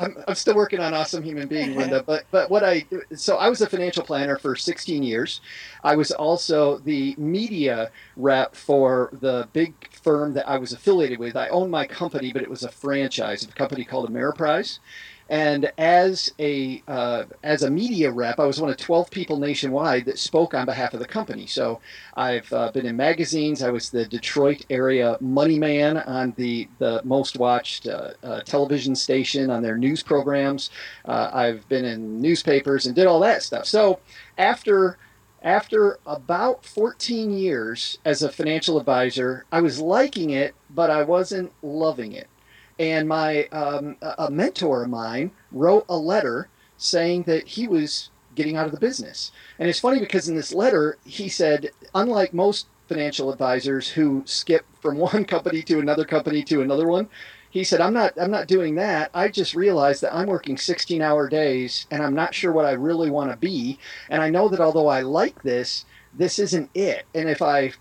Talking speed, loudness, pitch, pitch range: 185 wpm, -22 LUFS, 150 Hz, 135-175 Hz